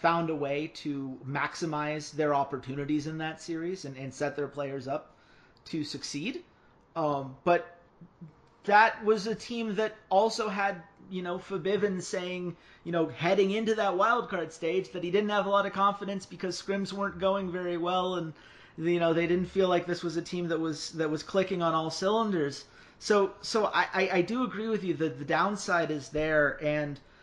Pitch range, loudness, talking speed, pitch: 155-195 Hz, -30 LUFS, 185 wpm, 175 Hz